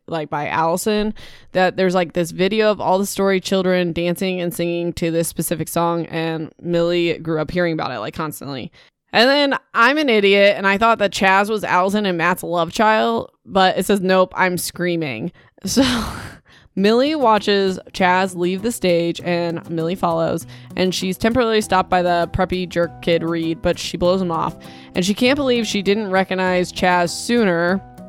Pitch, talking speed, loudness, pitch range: 180 Hz, 180 wpm, -18 LUFS, 170-200 Hz